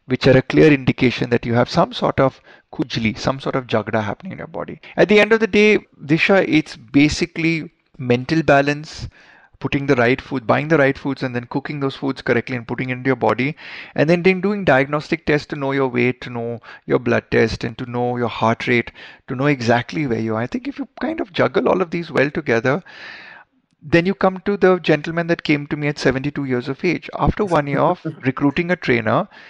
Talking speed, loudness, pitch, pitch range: 230 wpm, -18 LUFS, 145 Hz, 125-170 Hz